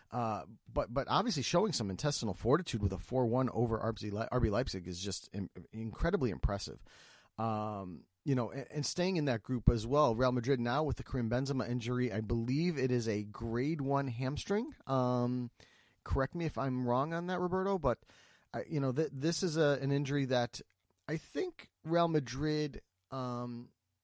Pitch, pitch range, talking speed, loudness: 125 Hz, 115-145 Hz, 180 wpm, -35 LUFS